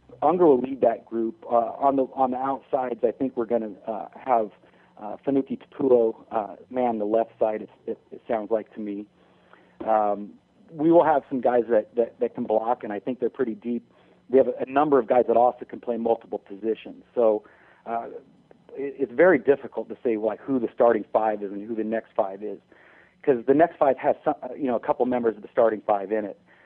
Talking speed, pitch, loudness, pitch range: 225 wpm, 115 Hz, -24 LUFS, 110-125 Hz